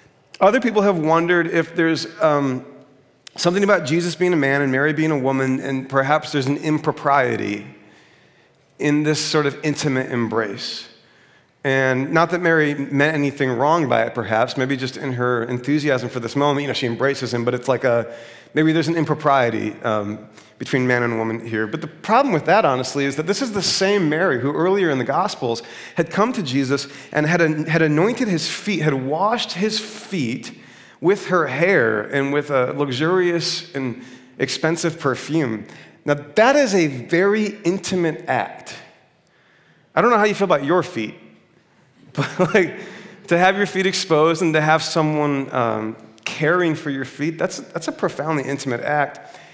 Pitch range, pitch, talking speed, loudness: 130-170 Hz, 150 Hz, 175 wpm, -19 LUFS